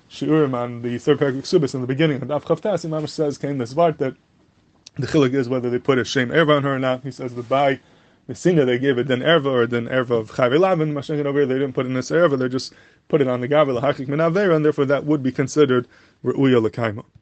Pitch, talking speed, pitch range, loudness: 135 Hz, 225 wpm, 125-150 Hz, -20 LUFS